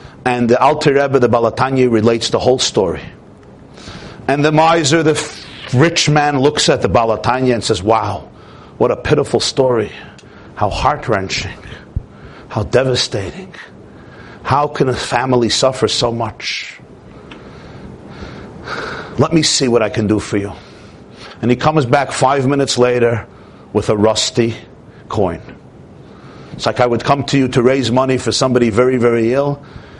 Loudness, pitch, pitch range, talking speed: -14 LUFS, 125 Hz, 115-140 Hz, 150 wpm